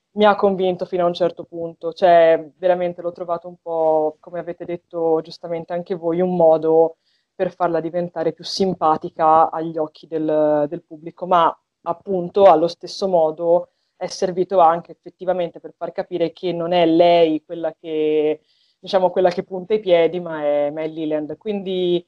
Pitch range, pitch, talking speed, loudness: 160-180 Hz, 170 Hz, 165 wpm, -19 LUFS